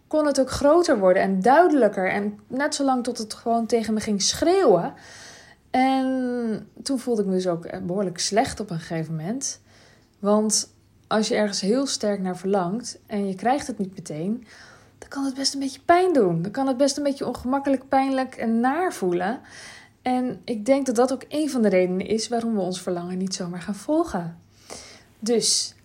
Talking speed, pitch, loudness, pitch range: 195 wpm, 230 Hz, -23 LUFS, 190-265 Hz